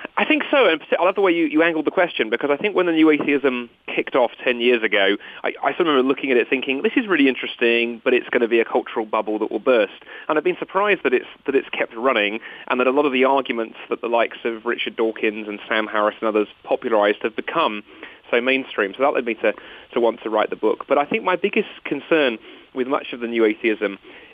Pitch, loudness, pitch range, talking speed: 130 Hz, -20 LUFS, 115-165 Hz, 255 wpm